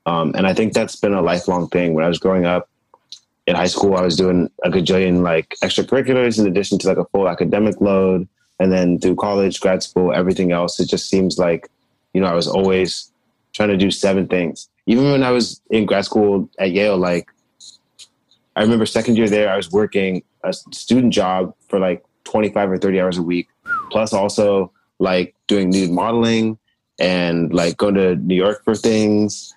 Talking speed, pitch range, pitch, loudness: 195 wpm, 90-105 Hz, 95 Hz, -17 LUFS